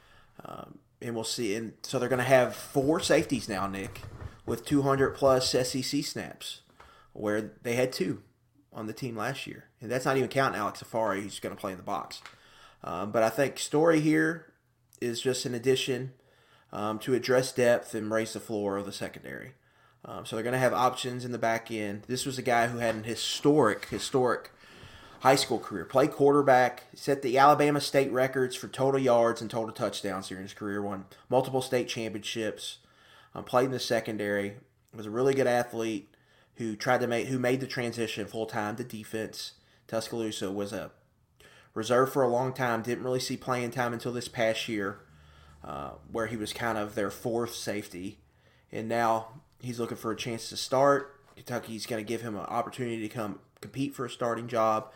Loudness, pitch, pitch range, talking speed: -29 LUFS, 115 Hz, 110-130 Hz, 190 wpm